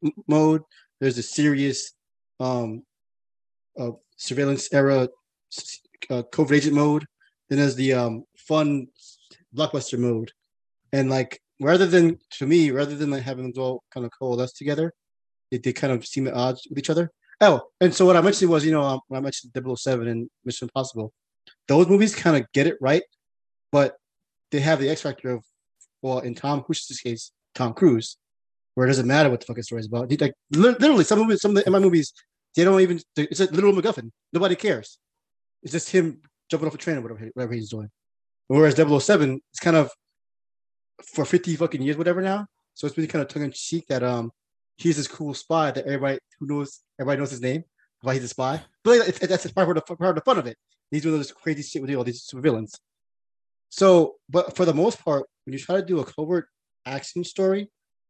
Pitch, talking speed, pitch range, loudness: 145 Hz, 205 wpm, 125-170 Hz, -23 LUFS